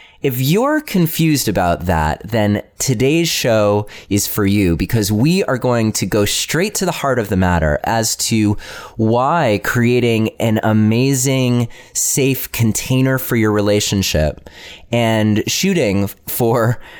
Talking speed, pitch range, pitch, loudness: 135 wpm, 105-130 Hz, 115 Hz, -16 LUFS